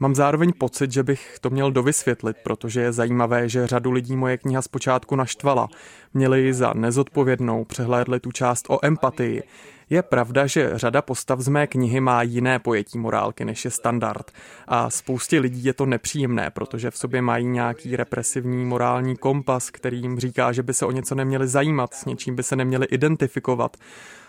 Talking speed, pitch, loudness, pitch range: 180 wpm, 130 Hz, -22 LUFS, 120-135 Hz